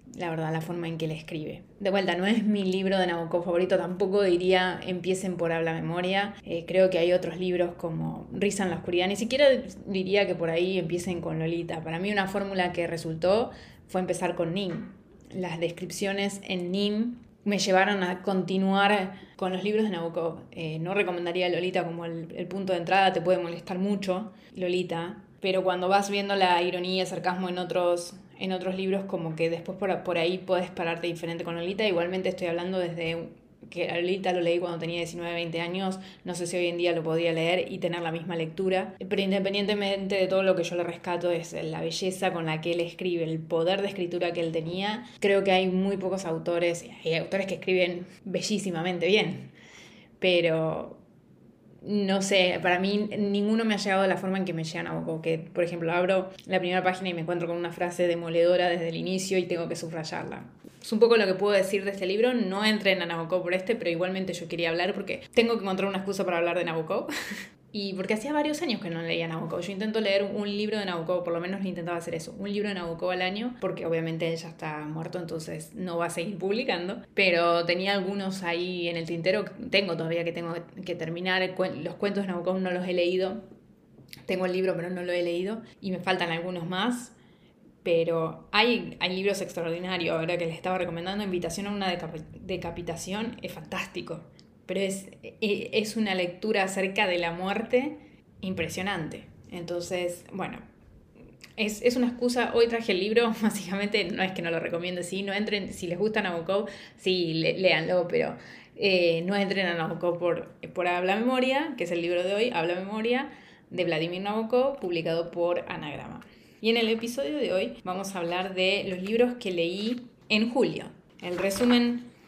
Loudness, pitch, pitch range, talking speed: -28 LUFS, 185 Hz, 170-195 Hz, 200 wpm